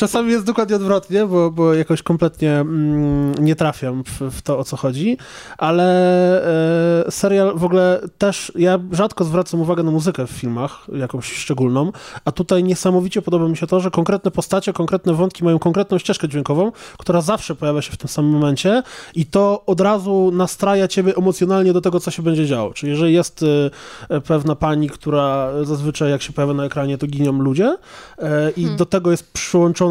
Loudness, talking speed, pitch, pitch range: -18 LUFS, 175 wpm, 170 Hz, 150-185 Hz